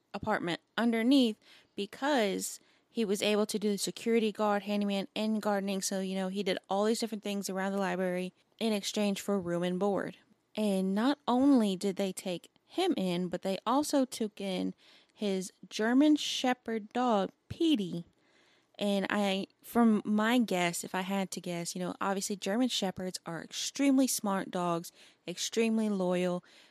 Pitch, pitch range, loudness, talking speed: 205 Hz, 190-230 Hz, -31 LUFS, 160 wpm